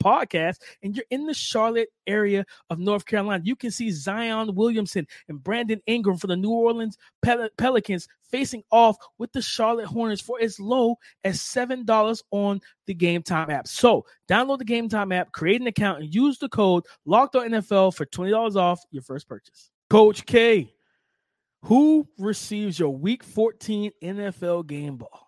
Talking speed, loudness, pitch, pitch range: 170 wpm, -23 LUFS, 215 Hz, 190-230 Hz